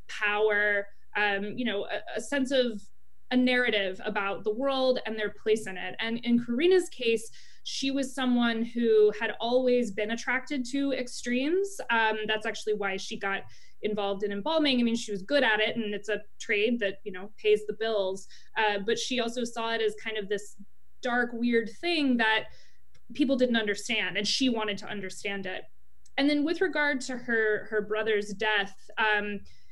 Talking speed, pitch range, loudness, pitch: 185 wpm, 210-250 Hz, -28 LUFS, 220 Hz